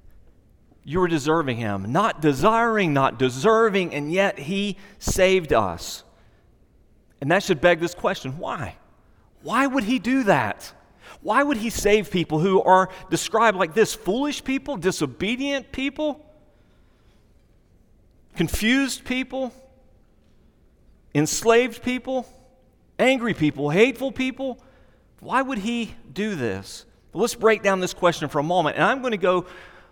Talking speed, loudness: 130 wpm, -22 LUFS